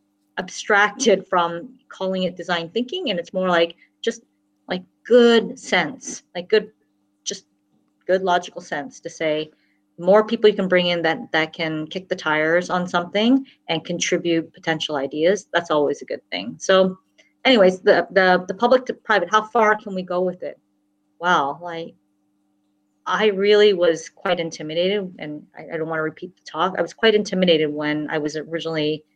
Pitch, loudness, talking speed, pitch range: 175 Hz, -20 LUFS, 175 wpm, 155-200 Hz